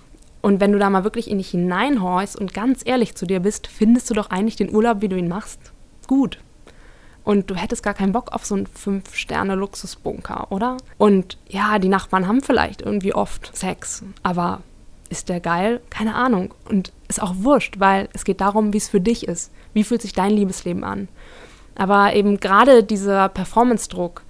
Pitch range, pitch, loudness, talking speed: 195-225 Hz, 205 Hz, -20 LUFS, 195 wpm